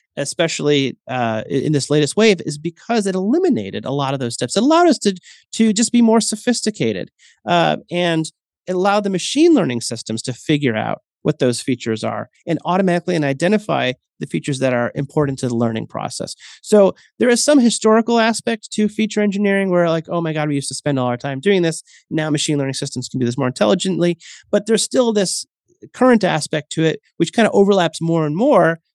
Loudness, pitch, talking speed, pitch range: -18 LUFS, 165 Hz, 205 wpm, 140-210 Hz